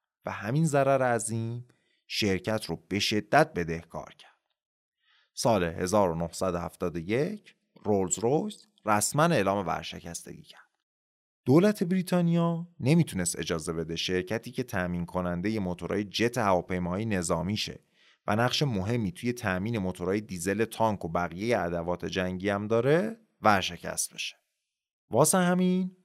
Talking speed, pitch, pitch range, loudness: 115 wpm, 105 Hz, 90-125 Hz, -28 LUFS